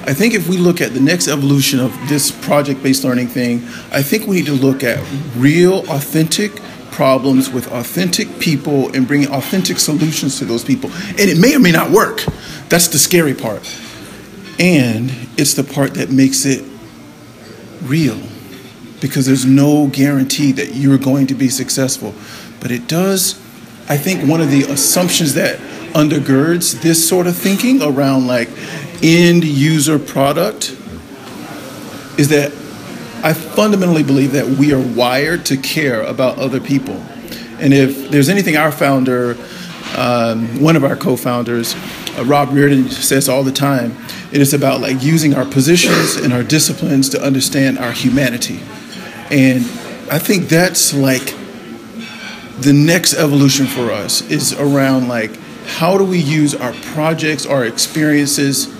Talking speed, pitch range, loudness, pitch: 155 wpm, 130-160 Hz, -13 LUFS, 140 Hz